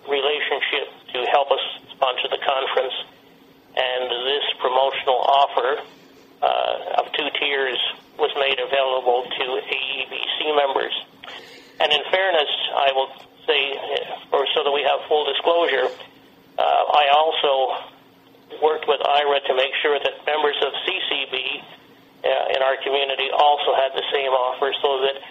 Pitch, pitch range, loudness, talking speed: 140 Hz, 135-145 Hz, -21 LUFS, 140 wpm